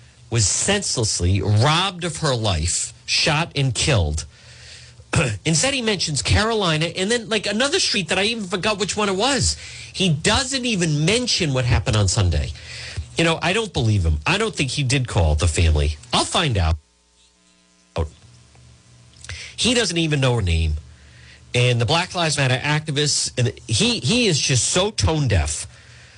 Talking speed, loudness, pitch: 165 wpm, -20 LUFS, 130 Hz